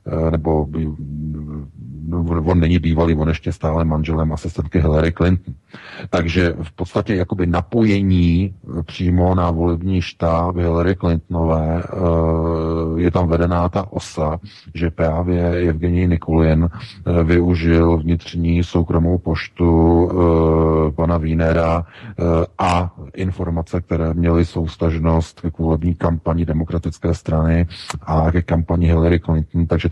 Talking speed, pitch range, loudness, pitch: 105 wpm, 80-90 Hz, -18 LUFS, 85 Hz